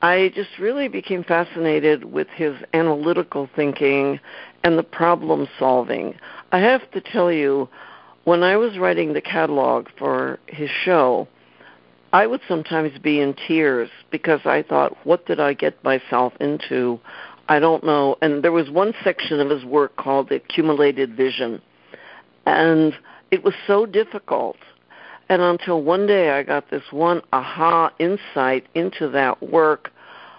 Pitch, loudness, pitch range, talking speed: 155 Hz, -20 LUFS, 140-175 Hz, 145 wpm